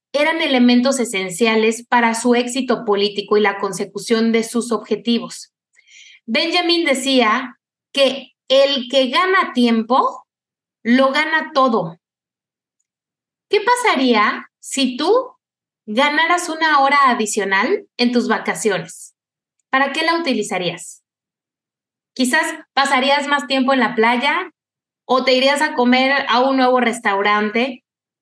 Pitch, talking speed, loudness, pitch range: 255 Hz, 115 wpm, -16 LUFS, 225-285 Hz